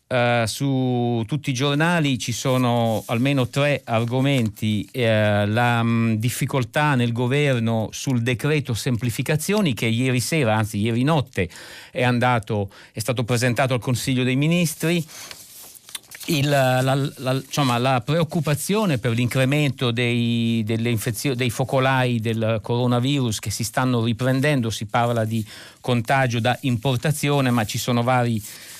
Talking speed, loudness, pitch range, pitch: 130 wpm, -21 LUFS, 115-140 Hz, 125 Hz